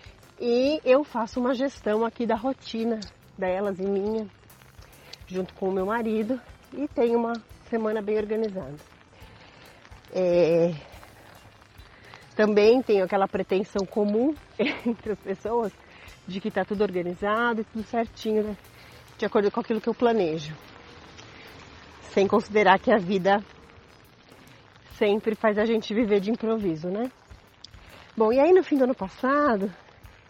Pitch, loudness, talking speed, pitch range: 210 Hz, -25 LUFS, 135 wpm, 185-230 Hz